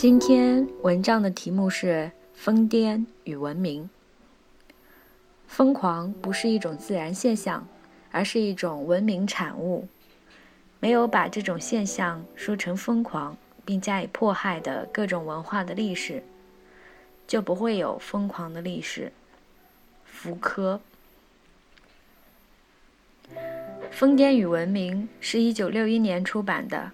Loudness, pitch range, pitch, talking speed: -25 LUFS, 175-220 Hz, 195 Hz, 180 characters per minute